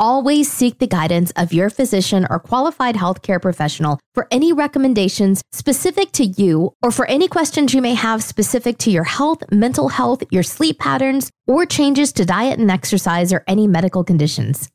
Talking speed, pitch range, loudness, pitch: 175 wpm, 185-270 Hz, -16 LUFS, 220 Hz